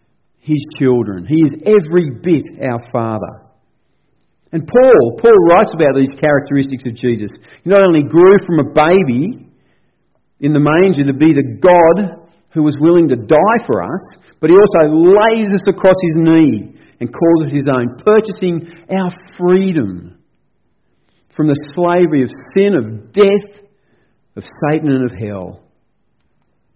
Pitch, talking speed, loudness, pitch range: 160 Hz, 150 wpm, -12 LUFS, 135-185 Hz